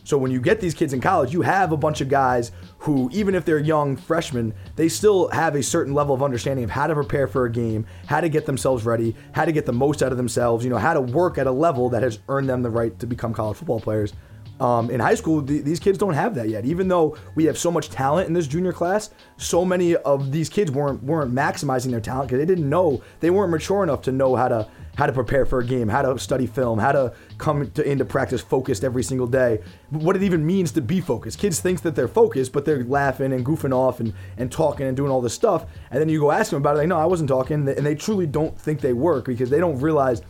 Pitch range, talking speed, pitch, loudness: 125-160 Hz, 270 wpm, 140 Hz, -22 LUFS